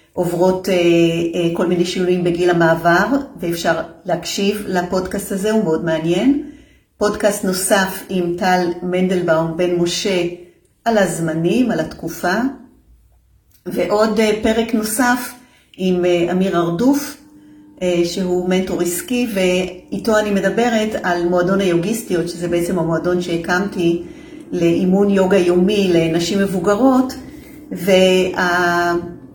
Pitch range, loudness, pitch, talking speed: 175-215 Hz, -17 LUFS, 185 Hz, 110 wpm